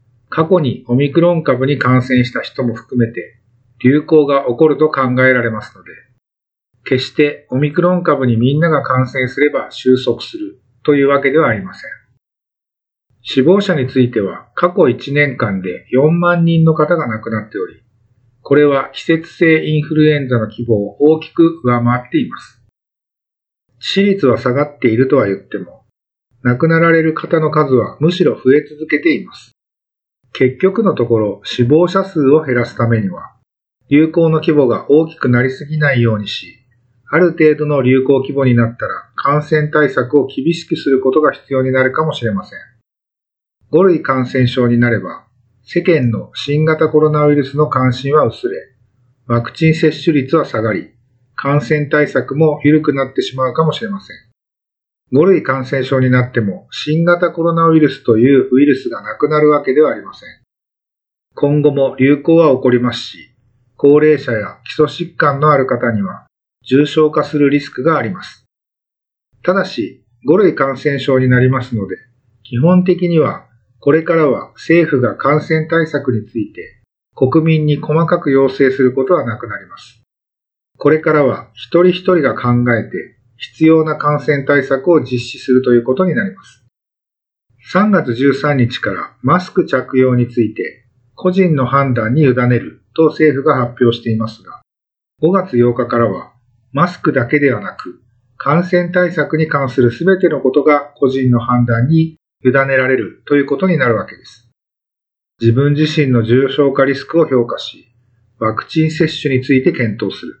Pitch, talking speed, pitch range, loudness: 135 Hz, 310 characters per minute, 125-155 Hz, -13 LUFS